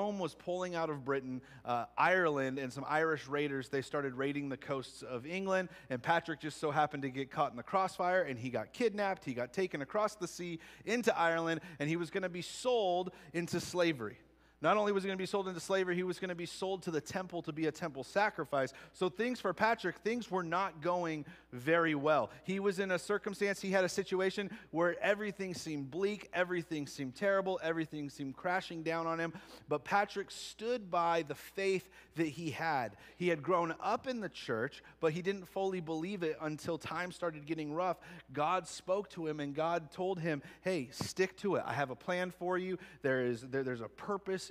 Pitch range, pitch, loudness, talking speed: 150-190 Hz, 170 Hz, -36 LUFS, 210 wpm